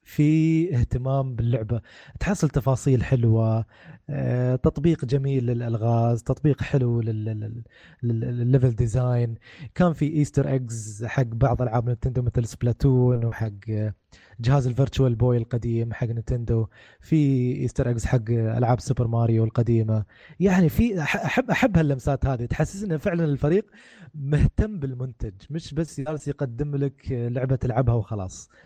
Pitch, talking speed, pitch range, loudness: 125 Hz, 120 wpm, 115-140 Hz, -24 LUFS